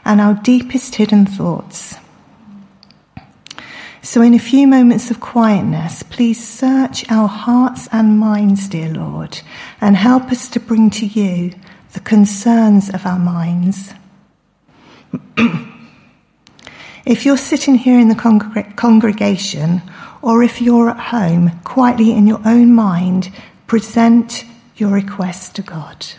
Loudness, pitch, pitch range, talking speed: -13 LUFS, 215 Hz, 195-235 Hz, 125 wpm